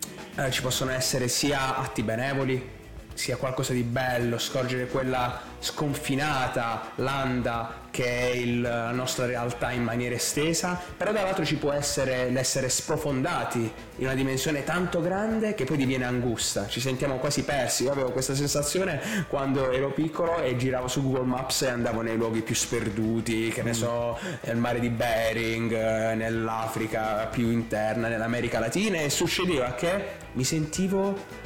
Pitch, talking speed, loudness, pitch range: 130 Hz, 150 wpm, -27 LUFS, 115-140 Hz